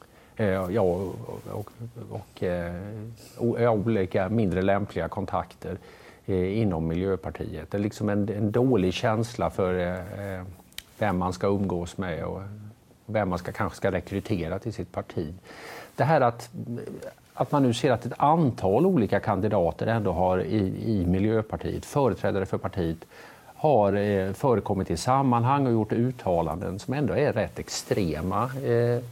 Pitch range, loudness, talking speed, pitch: 90-115 Hz, -26 LUFS, 140 wpm, 100 Hz